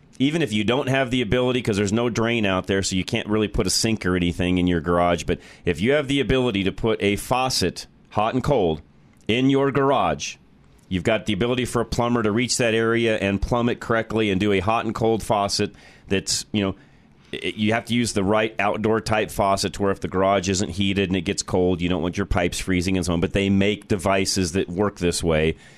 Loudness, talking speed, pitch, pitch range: -22 LUFS, 240 wpm, 105 Hz, 95-115 Hz